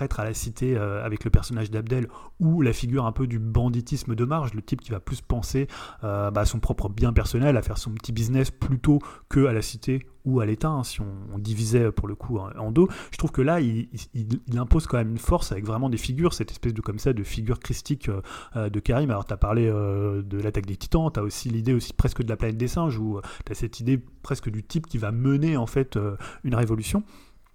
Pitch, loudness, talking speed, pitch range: 115 Hz, -26 LUFS, 230 wpm, 105-130 Hz